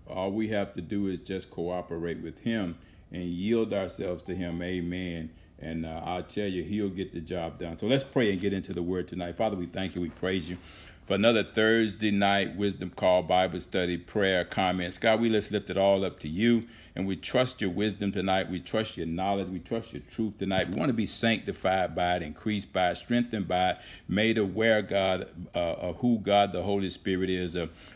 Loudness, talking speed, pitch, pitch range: -29 LUFS, 220 wpm, 95 Hz, 90-105 Hz